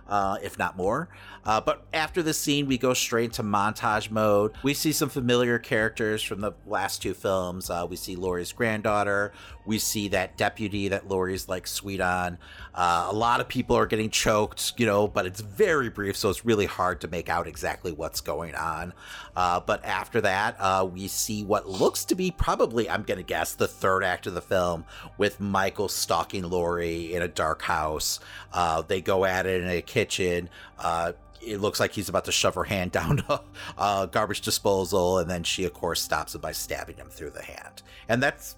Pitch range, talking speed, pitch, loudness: 90-110 Hz, 205 wpm, 100 Hz, -26 LUFS